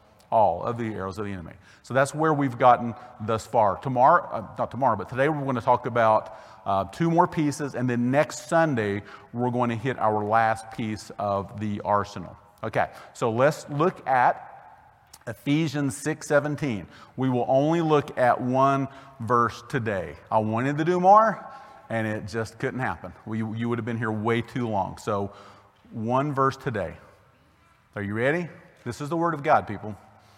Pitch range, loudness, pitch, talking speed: 110-140 Hz, -25 LUFS, 120 Hz, 180 wpm